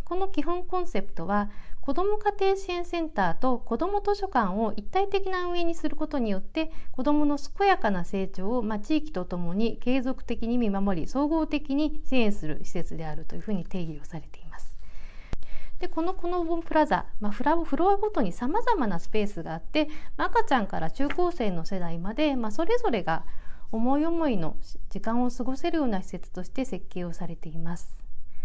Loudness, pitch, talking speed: -29 LUFS, 245 Hz, 385 characters per minute